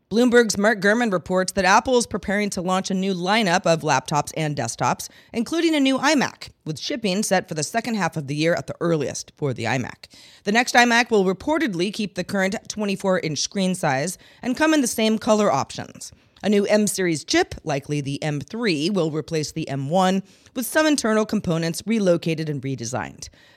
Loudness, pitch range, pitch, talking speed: -22 LUFS, 160-225 Hz, 190 Hz, 190 wpm